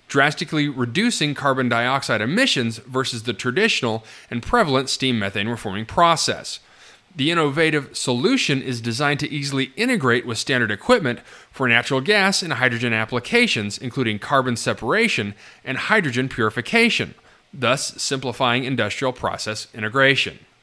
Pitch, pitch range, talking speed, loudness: 130 Hz, 120-145 Hz, 120 wpm, -20 LUFS